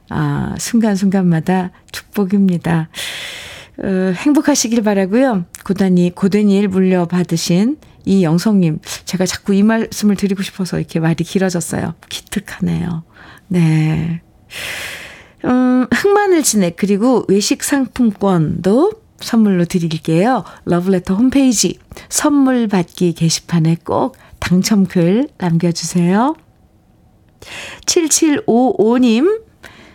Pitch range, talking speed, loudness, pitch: 175-235 Hz, 235 characters per minute, -15 LUFS, 195 Hz